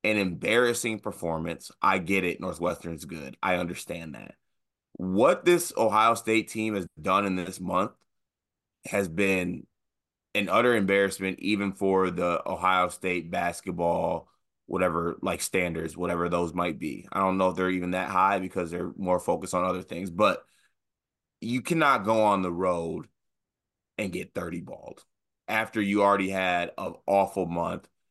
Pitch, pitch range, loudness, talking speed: 95 Hz, 90-100 Hz, -27 LUFS, 155 wpm